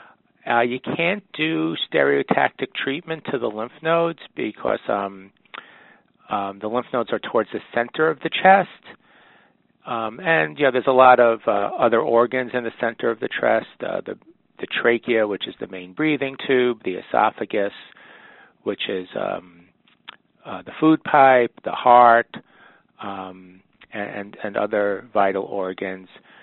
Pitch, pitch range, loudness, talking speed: 120 Hz, 100-135 Hz, -20 LUFS, 150 wpm